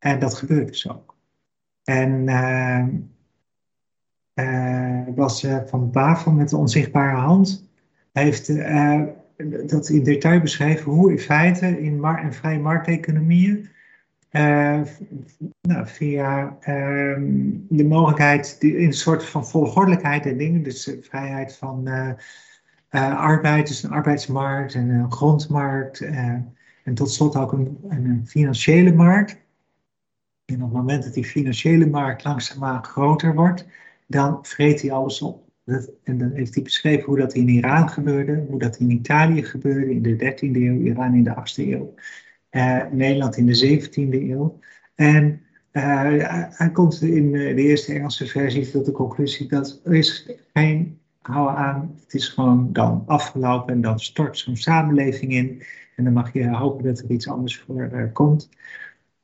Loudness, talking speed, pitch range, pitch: -20 LUFS, 155 wpm, 130-155 Hz, 140 Hz